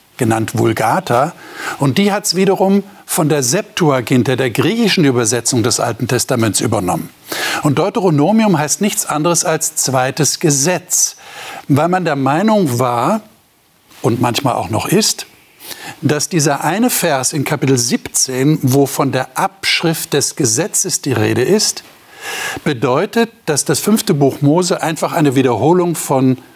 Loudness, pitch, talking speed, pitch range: -14 LUFS, 155 Hz, 140 wpm, 135-190 Hz